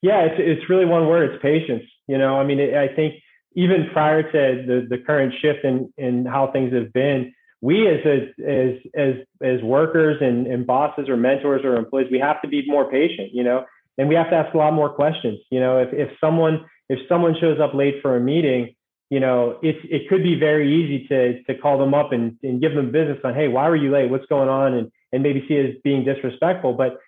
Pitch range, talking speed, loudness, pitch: 130-155 Hz, 240 wpm, -20 LUFS, 140 Hz